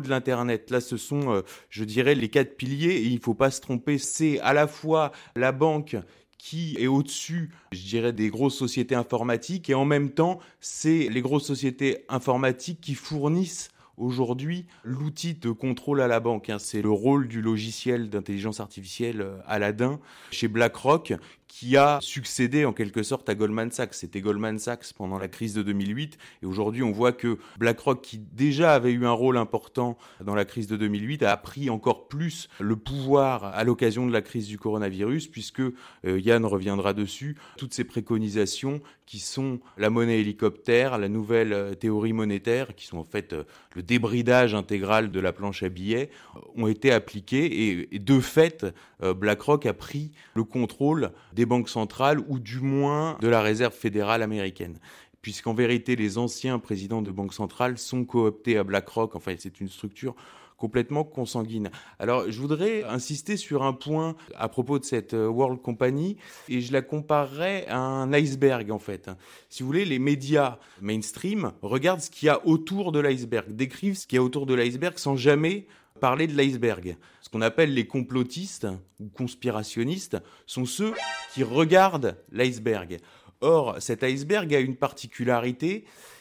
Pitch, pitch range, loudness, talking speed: 125 Hz, 110-140 Hz, -26 LUFS, 175 wpm